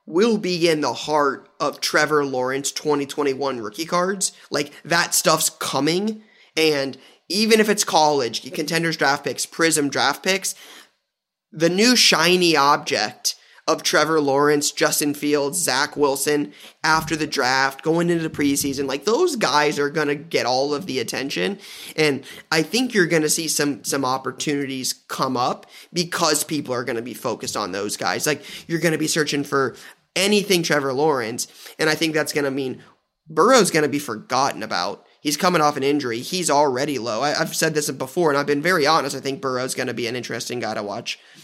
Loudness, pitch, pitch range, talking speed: -20 LUFS, 150 Hz, 140-165 Hz, 175 wpm